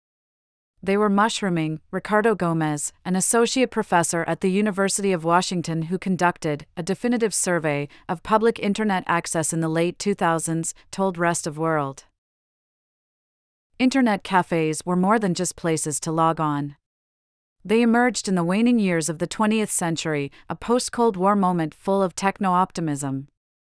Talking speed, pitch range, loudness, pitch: 145 wpm, 165-205 Hz, -22 LUFS, 180 Hz